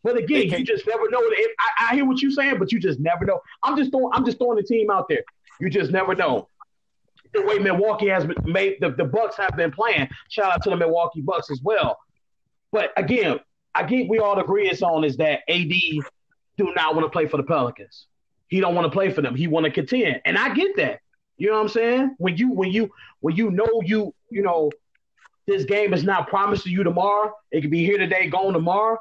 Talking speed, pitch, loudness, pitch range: 240 wpm, 200 Hz, -22 LUFS, 180-240 Hz